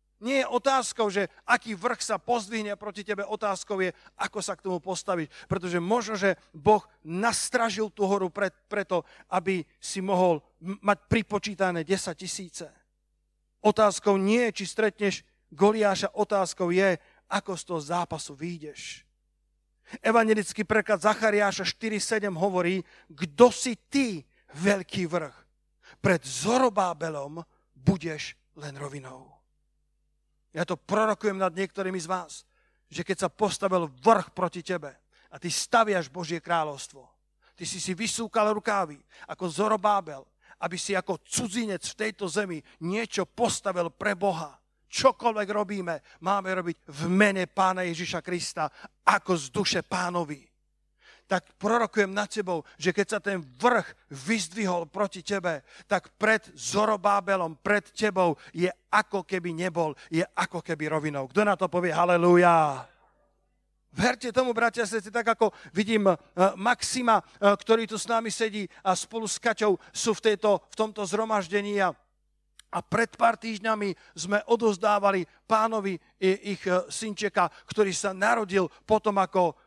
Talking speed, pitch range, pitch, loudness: 135 wpm, 175-215 Hz, 195 Hz, -27 LUFS